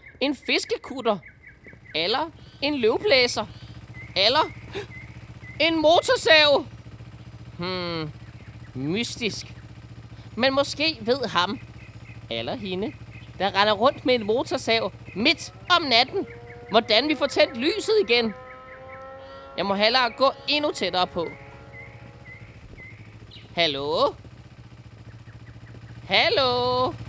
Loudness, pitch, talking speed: -22 LUFS, 175 Hz, 90 wpm